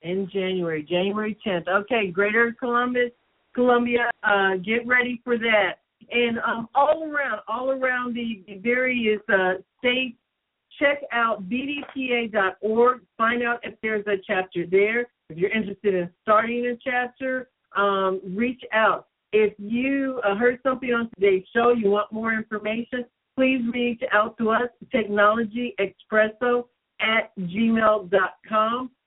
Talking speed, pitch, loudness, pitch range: 130 wpm, 225 Hz, -23 LUFS, 205-245 Hz